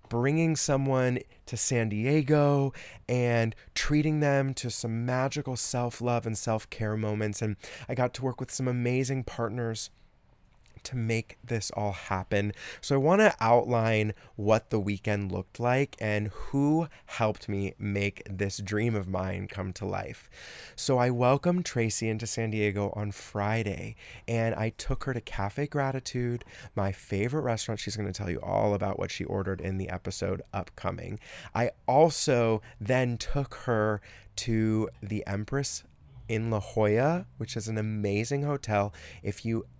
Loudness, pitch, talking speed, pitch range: -29 LUFS, 110 Hz, 155 wpm, 105-125 Hz